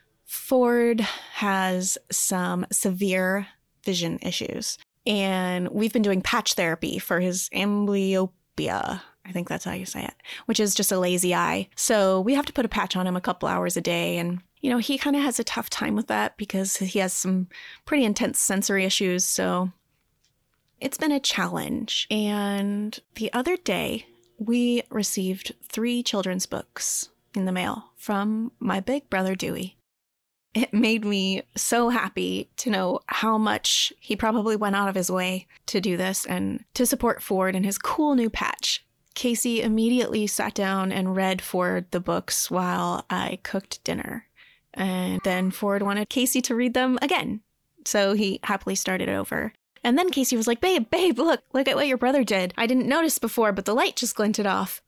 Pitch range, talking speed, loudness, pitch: 185-240 Hz, 180 wpm, -25 LUFS, 205 Hz